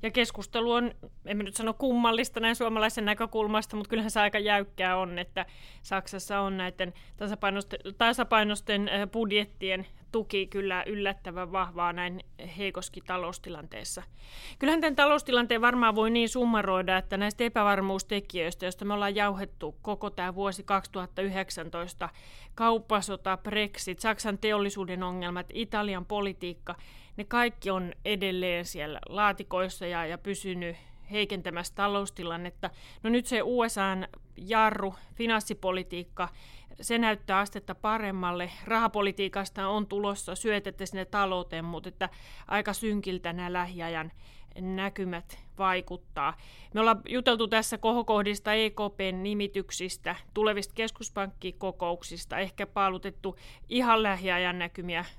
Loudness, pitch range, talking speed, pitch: -30 LUFS, 185-215 Hz, 115 wpm, 195 Hz